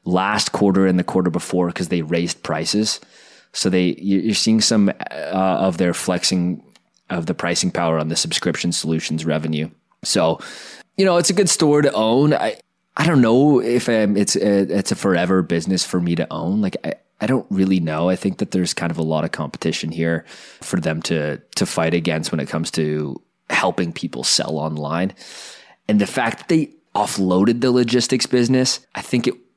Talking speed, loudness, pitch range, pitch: 195 wpm, -19 LUFS, 85-110 Hz, 95 Hz